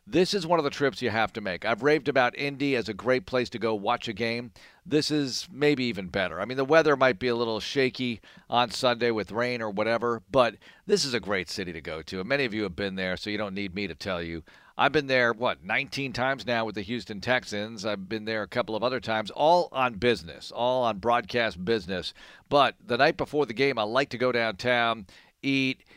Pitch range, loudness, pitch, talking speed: 110-135 Hz, -27 LUFS, 120 Hz, 245 wpm